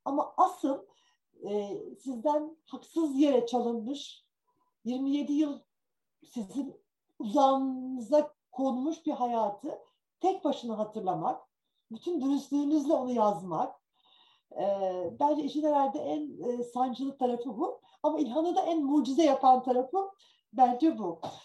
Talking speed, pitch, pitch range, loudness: 110 wpm, 280 Hz, 250-310 Hz, -30 LUFS